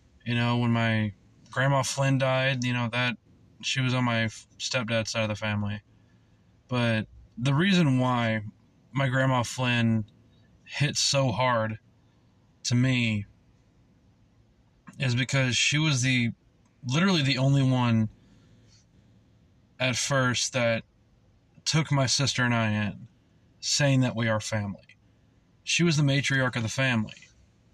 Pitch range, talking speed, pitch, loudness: 110-130 Hz, 130 wpm, 120 Hz, -26 LUFS